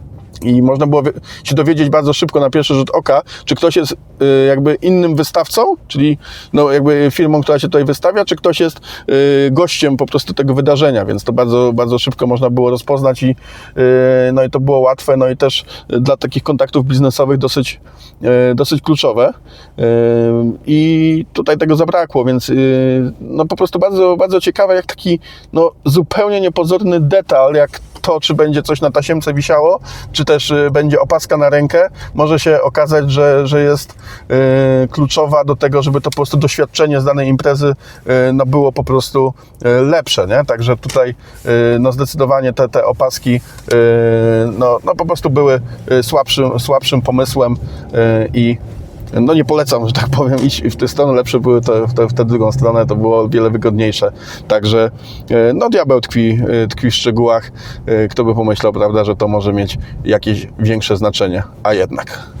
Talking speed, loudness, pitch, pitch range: 170 wpm, -12 LUFS, 135 Hz, 120-150 Hz